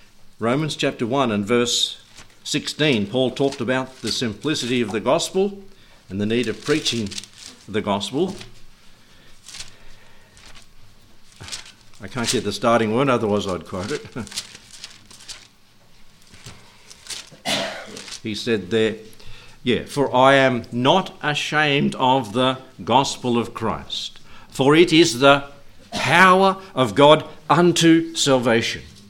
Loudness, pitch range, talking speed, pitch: -19 LUFS, 105-140 Hz, 110 wpm, 115 Hz